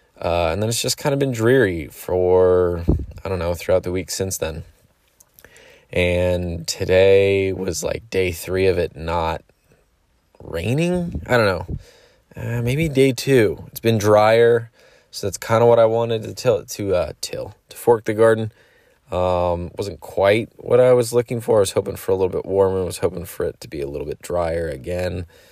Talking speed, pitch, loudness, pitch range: 195 wpm, 95 Hz, -19 LUFS, 90-120 Hz